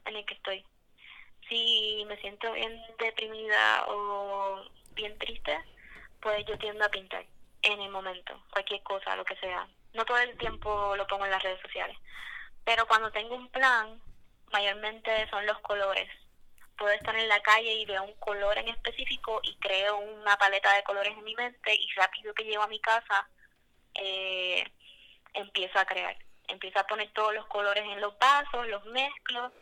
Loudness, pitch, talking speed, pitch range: -29 LUFS, 210 Hz, 175 wpm, 200-225 Hz